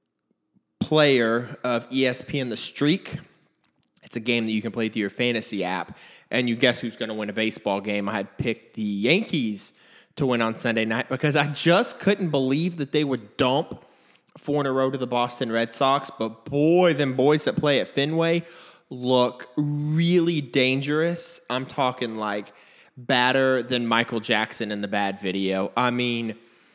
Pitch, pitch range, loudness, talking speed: 125 Hz, 110-145 Hz, -24 LUFS, 175 wpm